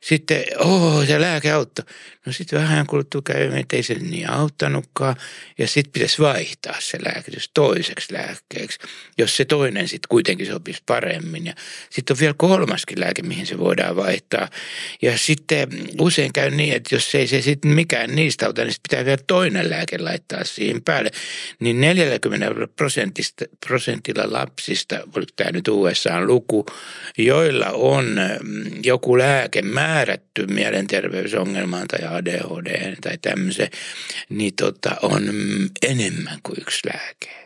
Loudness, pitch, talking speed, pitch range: -20 LUFS, 150 Hz, 145 wpm, 125-165 Hz